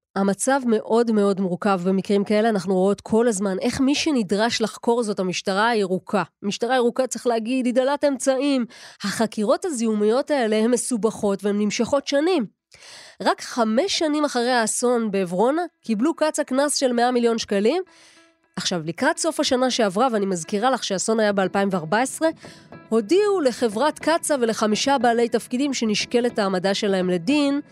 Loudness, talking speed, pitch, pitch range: -21 LUFS, 145 wpm, 235 Hz, 205-275 Hz